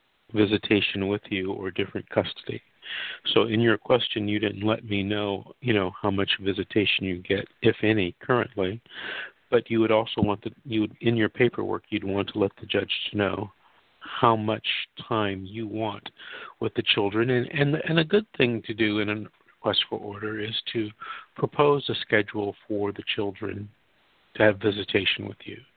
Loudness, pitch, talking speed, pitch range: -26 LUFS, 105 Hz, 180 wpm, 100-115 Hz